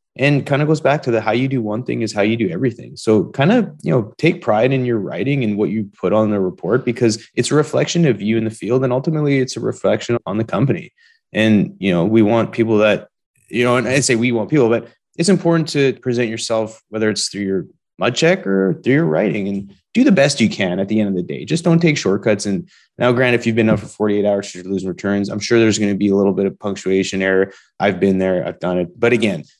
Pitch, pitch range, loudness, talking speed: 115 Hz, 100-135 Hz, -17 LUFS, 265 wpm